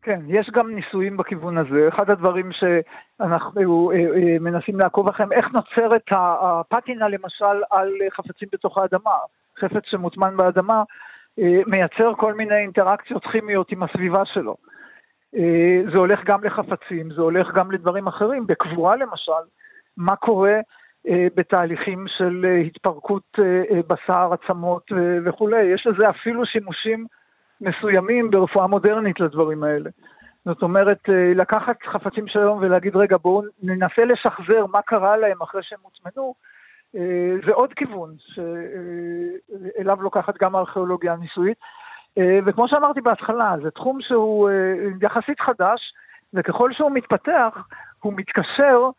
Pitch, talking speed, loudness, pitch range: 195 Hz, 120 wpm, -20 LUFS, 180-215 Hz